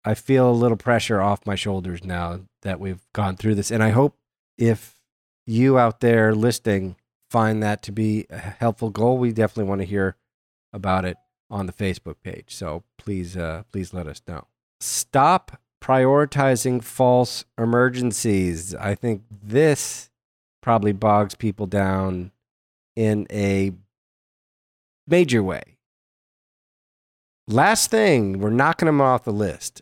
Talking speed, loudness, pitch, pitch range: 140 wpm, -21 LUFS, 105 Hz, 95-120 Hz